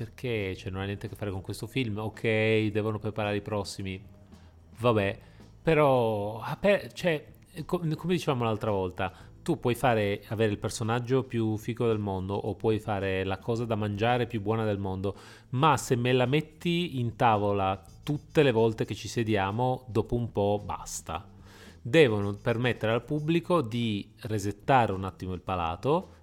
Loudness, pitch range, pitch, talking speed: -29 LUFS, 100-120 Hz, 110 Hz, 160 wpm